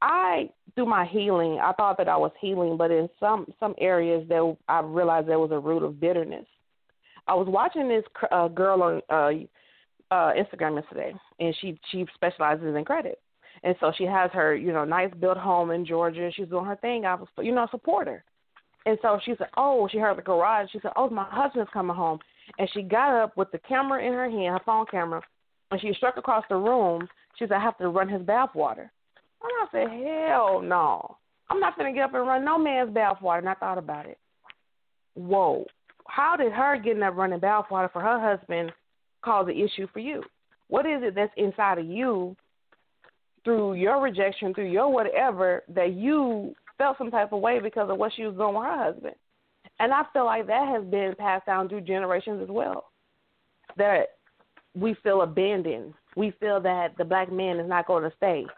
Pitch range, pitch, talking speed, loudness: 175-225 Hz, 195 Hz, 205 wpm, -26 LUFS